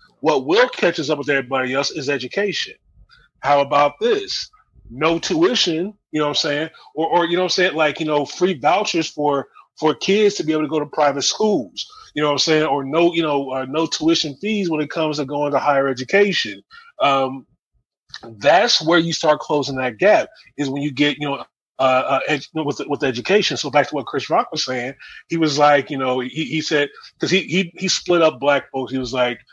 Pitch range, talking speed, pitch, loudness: 140-170 Hz, 225 wpm, 150 Hz, -19 LUFS